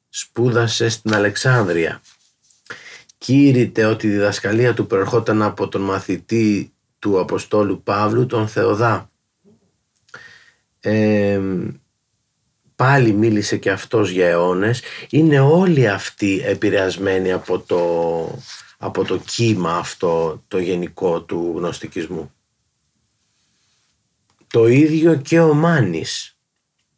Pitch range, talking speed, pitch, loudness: 95-120 Hz, 95 wpm, 110 Hz, -18 LUFS